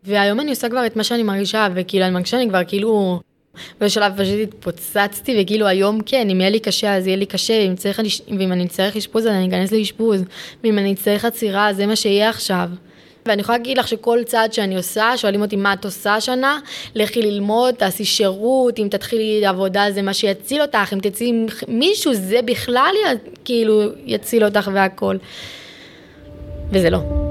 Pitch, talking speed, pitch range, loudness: 210 Hz, 180 wpm, 195-225 Hz, -18 LUFS